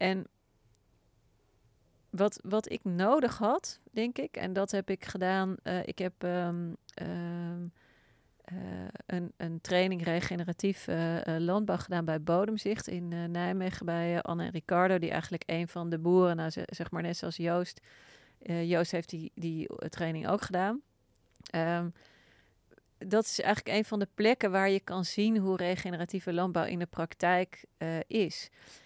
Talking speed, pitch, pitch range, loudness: 160 wpm, 175 Hz, 170-190 Hz, -32 LUFS